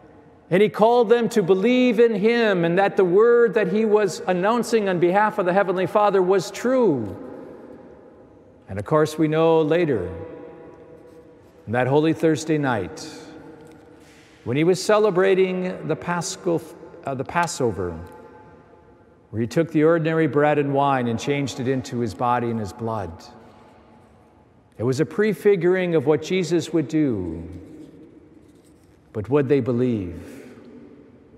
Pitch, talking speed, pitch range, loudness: 160 Hz, 140 wpm, 135-190 Hz, -20 LUFS